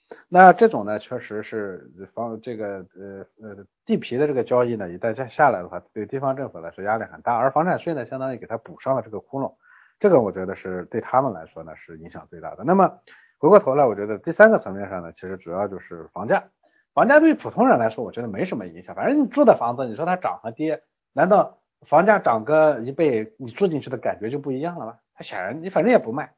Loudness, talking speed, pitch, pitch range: -21 LUFS, 355 characters per minute, 120 Hz, 105-155 Hz